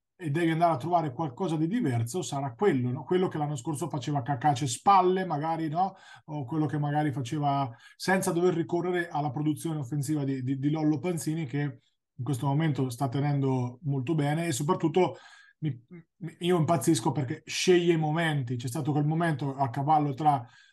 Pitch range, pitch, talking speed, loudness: 140-170 Hz, 155 Hz, 175 wpm, -28 LUFS